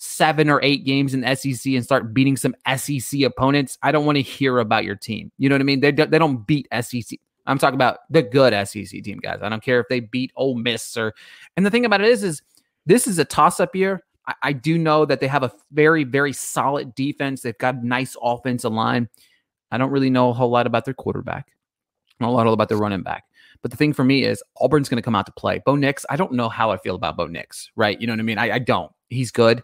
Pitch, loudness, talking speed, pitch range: 130 Hz, -20 LUFS, 265 wpm, 120-140 Hz